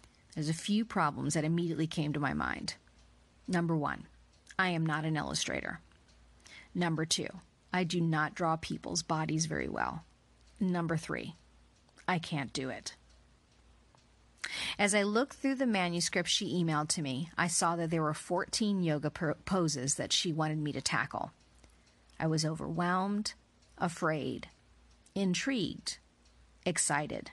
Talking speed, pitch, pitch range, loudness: 140 wpm, 160 Hz, 135-180 Hz, -33 LUFS